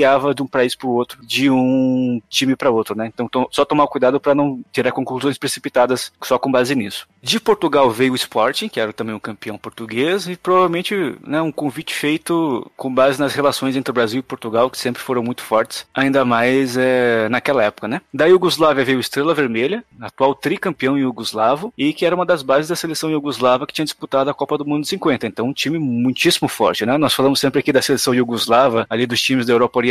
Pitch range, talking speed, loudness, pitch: 125-145 Hz, 220 wpm, -17 LUFS, 130 Hz